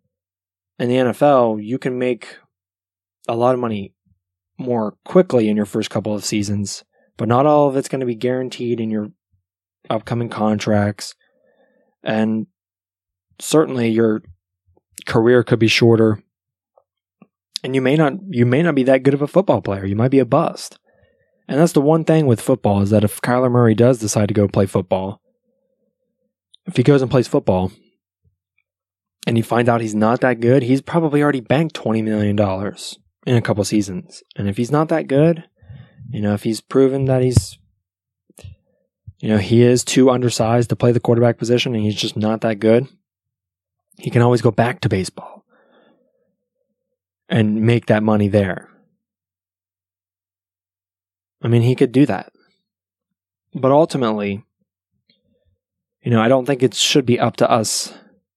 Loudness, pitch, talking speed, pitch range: -17 LUFS, 115 Hz, 165 wpm, 100-130 Hz